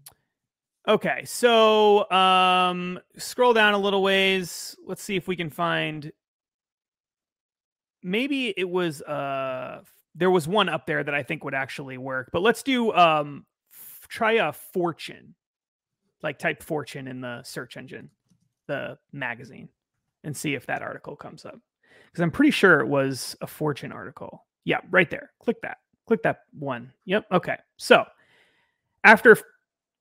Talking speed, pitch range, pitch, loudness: 150 wpm, 150-215 Hz, 180 Hz, -23 LUFS